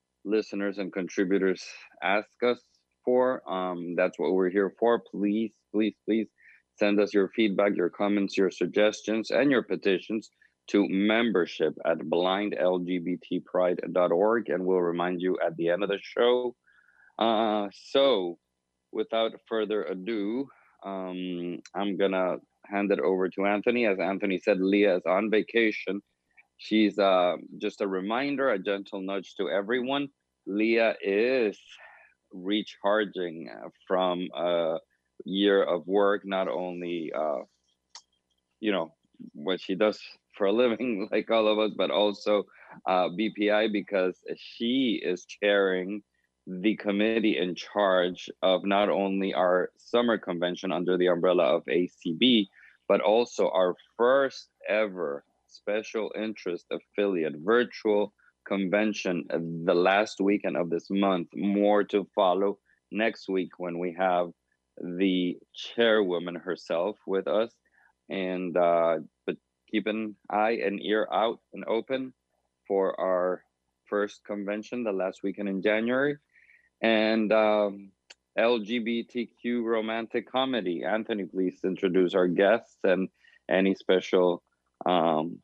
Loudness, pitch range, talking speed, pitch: -27 LUFS, 90-110 Hz, 125 wpm, 100 Hz